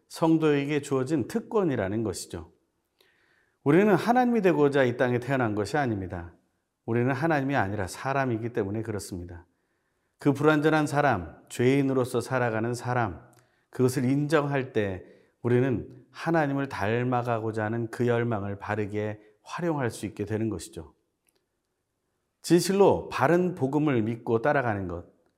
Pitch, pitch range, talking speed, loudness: 120 Hz, 105-145 Hz, 310 characters per minute, -26 LUFS